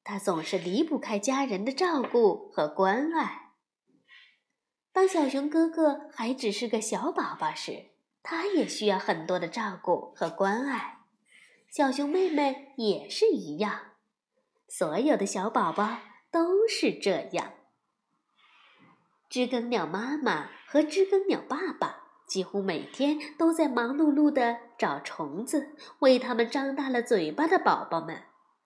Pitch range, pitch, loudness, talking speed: 220-325 Hz, 275 Hz, -28 LUFS, 195 characters per minute